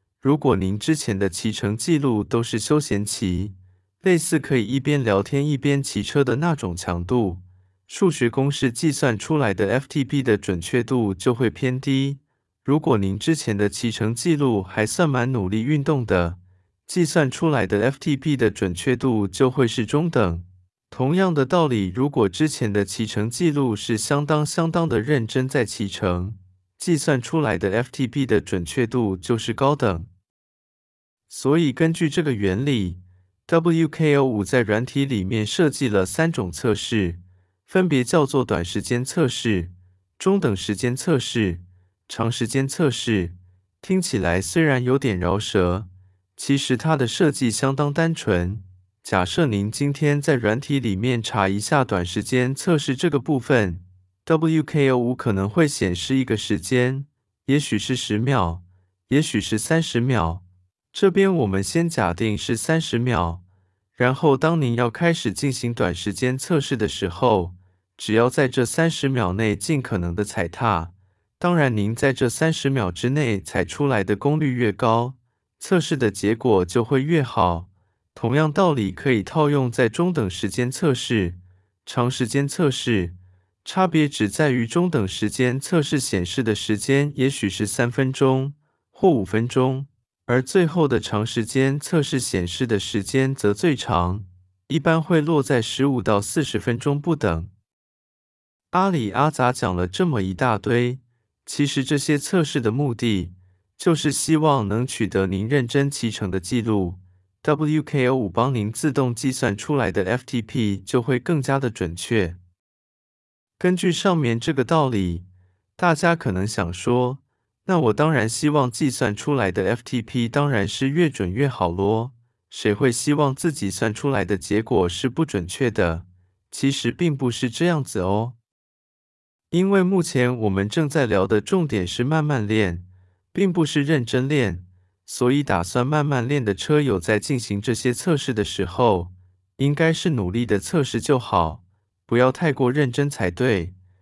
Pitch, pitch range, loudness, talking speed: 120 Hz, 100-145 Hz, -22 LUFS, 235 characters per minute